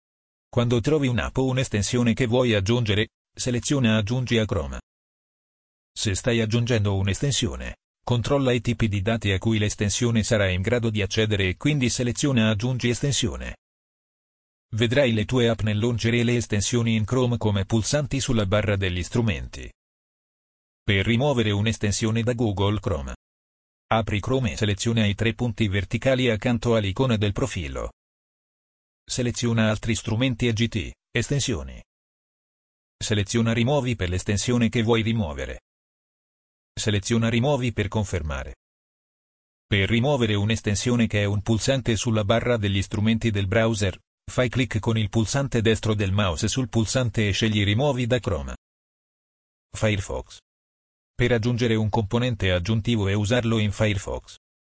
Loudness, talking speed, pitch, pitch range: -23 LUFS, 135 wpm, 110 Hz, 100-120 Hz